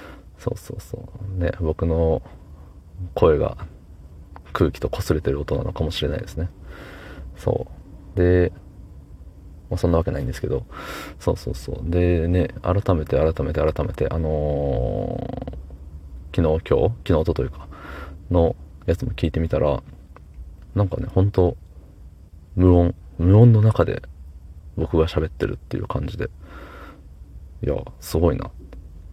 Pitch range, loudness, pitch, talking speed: 75-90 Hz, -22 LUFS, 80 Hz, 245 characters per minute